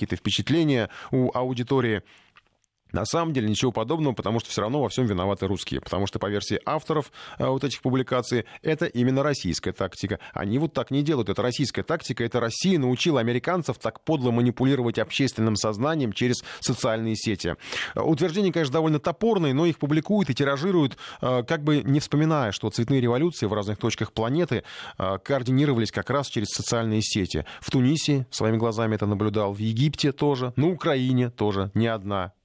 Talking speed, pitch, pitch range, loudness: 170 wpm, 125 Hz, 110-145 Hz, -25 LUFS